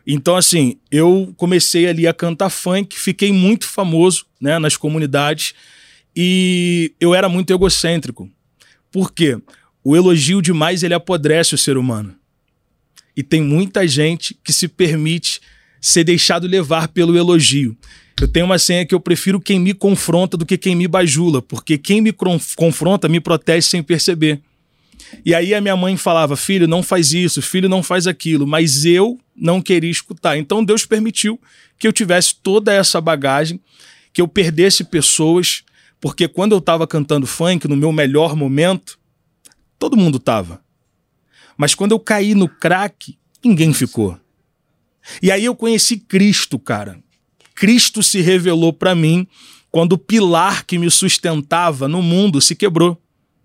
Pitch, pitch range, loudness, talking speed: 175 Hz, 155-190 Hz, -14 LUFS, 155 wpm